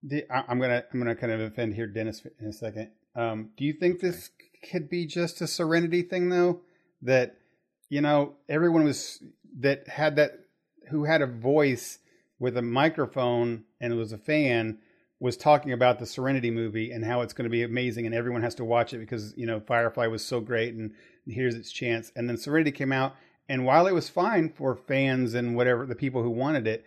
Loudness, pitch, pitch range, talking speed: -27 LUFS, 125 Hz, 115-150 Hz, 210 wpm